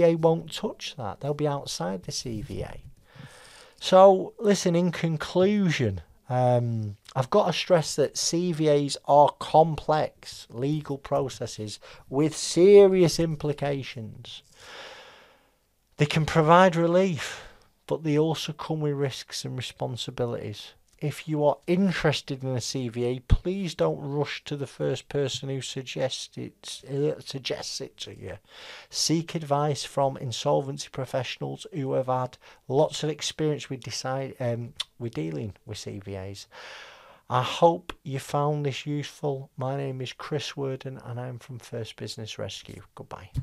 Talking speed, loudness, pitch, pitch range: 135 wpm, -26 LUFS, 140 Hz, 125-160 Hz